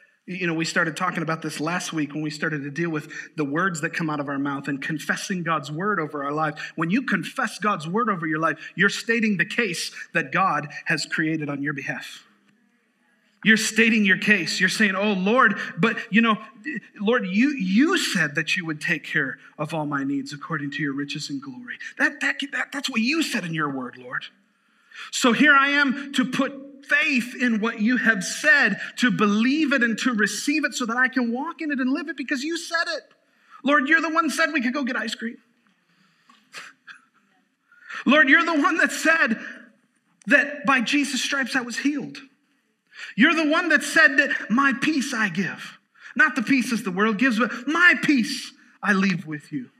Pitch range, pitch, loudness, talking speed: 180-275 Hz, 230 Hz, -22 LUFS, 205 wpm